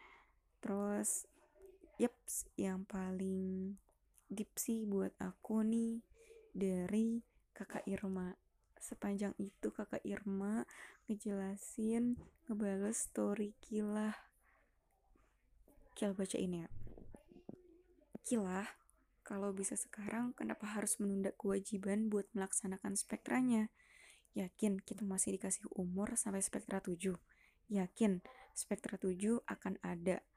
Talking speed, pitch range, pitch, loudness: 95 wpm, 195-230 Hz, 205 Hz, -41 LUFS